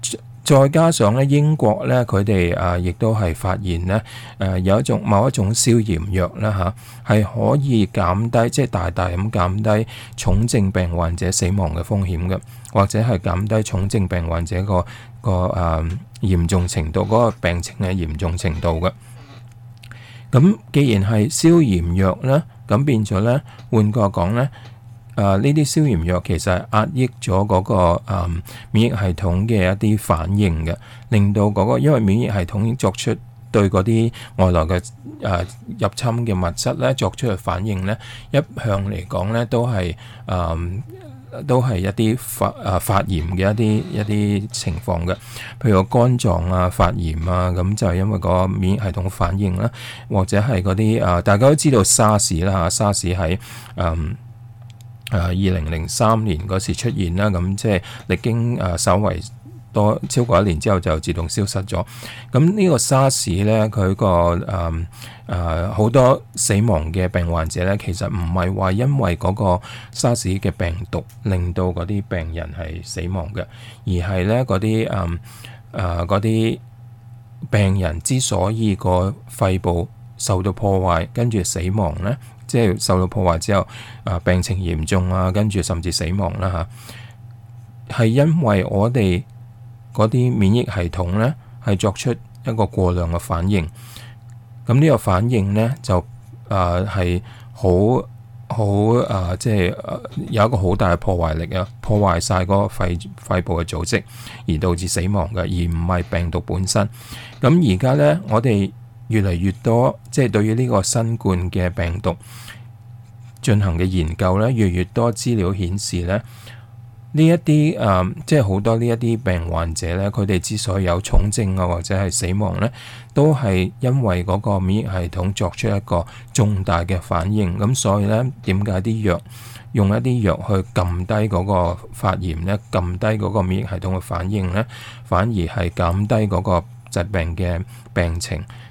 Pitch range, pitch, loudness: 90-115 Hz, 105 Hz, -19 LUFS